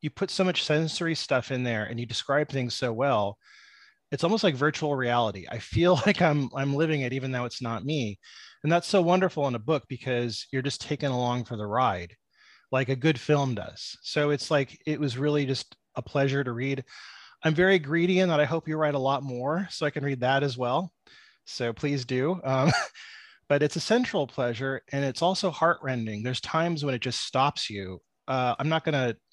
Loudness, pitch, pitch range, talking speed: -27 LUFS, 140 Hz, 125-160 Hz, 215 wpm